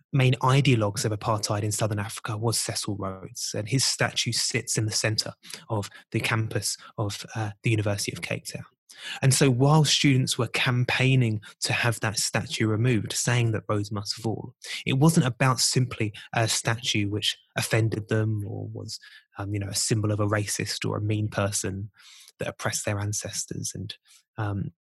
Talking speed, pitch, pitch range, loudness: 175 wpm, 110 Hz, 105-125 Hz, -26 LUFS